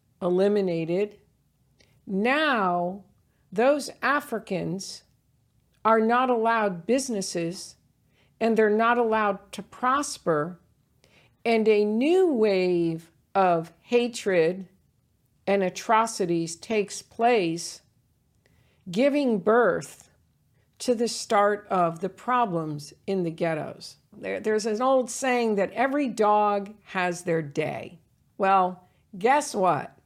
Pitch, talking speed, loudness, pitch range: 200 Hz, 100 wpm, -25 LUFS, 170-230 Hz